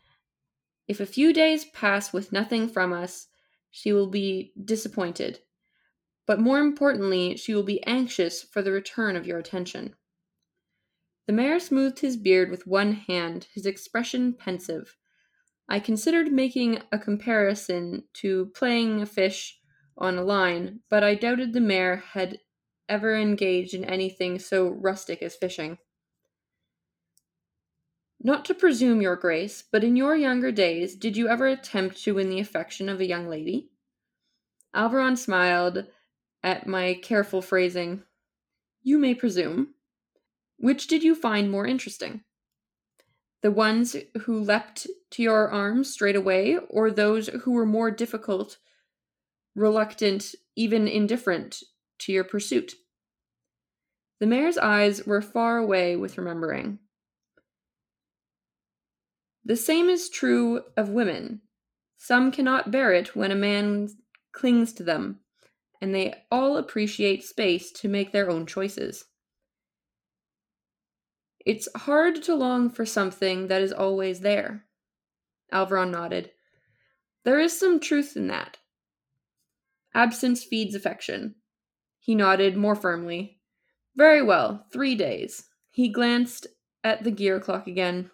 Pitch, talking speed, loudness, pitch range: 210 Hz, 130 wpm, -25 LUFS, 190-245 Hz